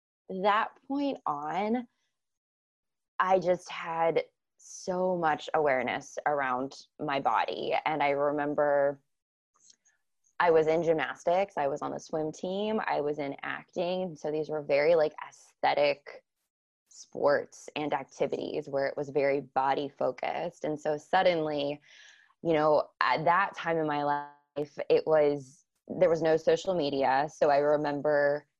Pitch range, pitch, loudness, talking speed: 145-180 Hz, 150 Hz, -29 LUFS, 135 wpm